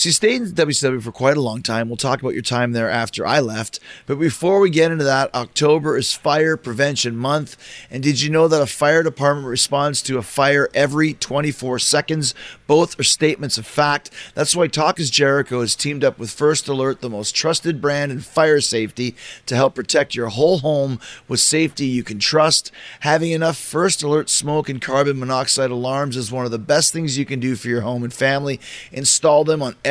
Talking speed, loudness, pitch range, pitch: 215 wpm, -18 LUFS, 125-150 Hz, 140 Hz